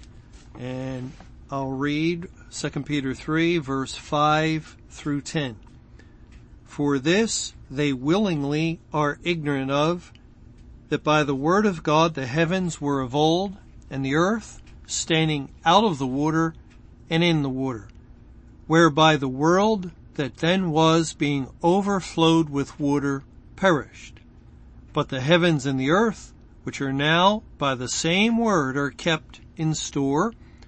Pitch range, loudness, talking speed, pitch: 140-165 Hz, -23 LUFS, 135 wpm, 150 Hz